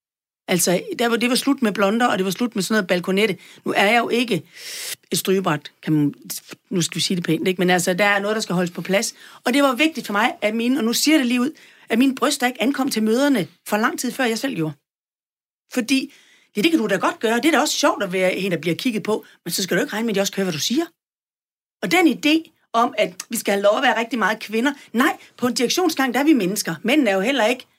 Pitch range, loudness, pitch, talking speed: 195-270 Hz, -20 LUFS, 230 Hz, 275 wpm